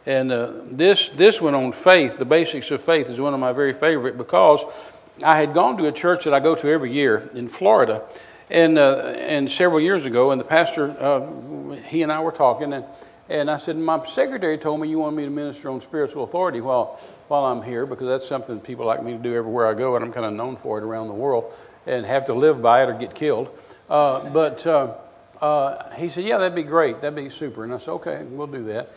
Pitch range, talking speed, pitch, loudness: 130-160 Hz, 245 wpm, 145 Hz, -20 LUFS